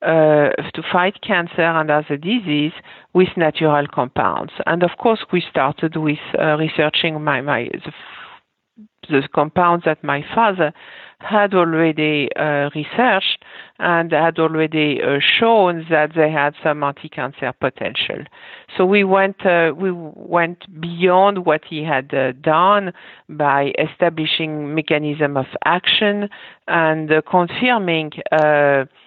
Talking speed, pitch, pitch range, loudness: 130 wpm, 160 Hz, 150-180 Hz, -17 LUFS